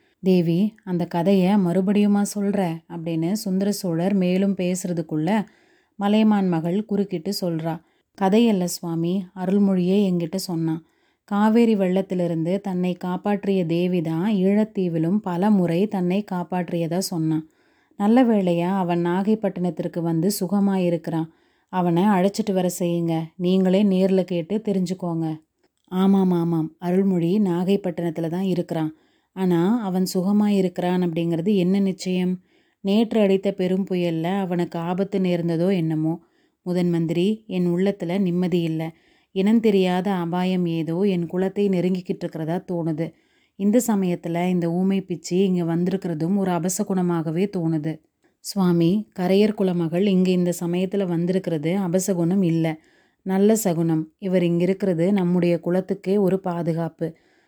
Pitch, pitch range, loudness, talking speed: 185 Hz, 170-195 Hz, -22 LUFS, 115 wpm